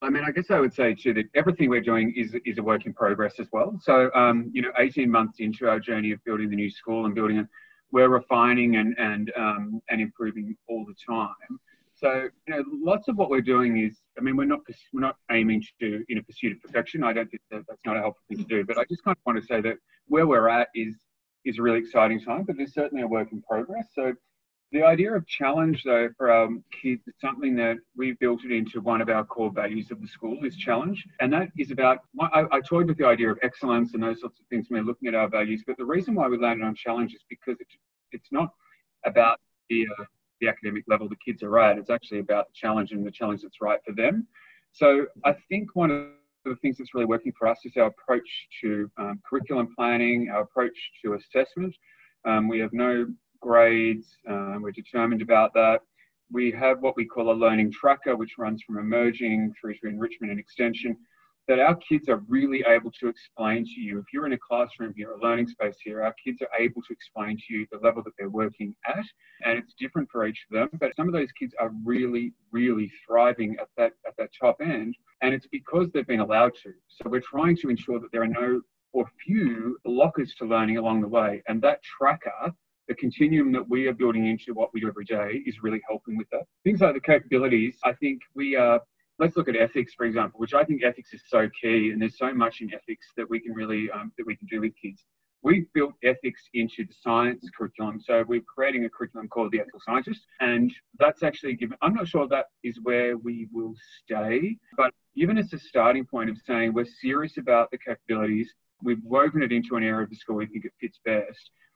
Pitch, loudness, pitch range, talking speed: 120 Hz, -25 LUFS, 110-140 Hz, 235 wpm